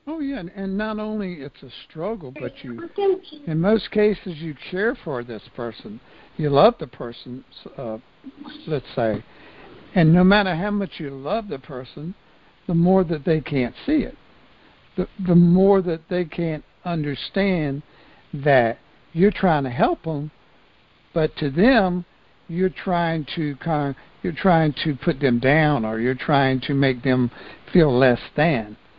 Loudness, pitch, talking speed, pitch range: -21 LUFS, 165 Hz, 160 wpm, 140-195 Hz